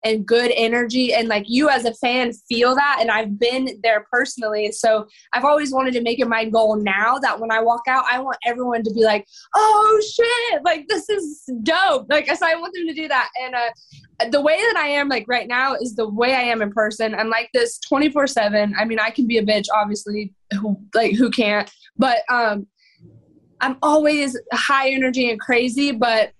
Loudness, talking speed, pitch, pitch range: -19 LUFS, 215 wpm, 245 Hz, 220-285 Hz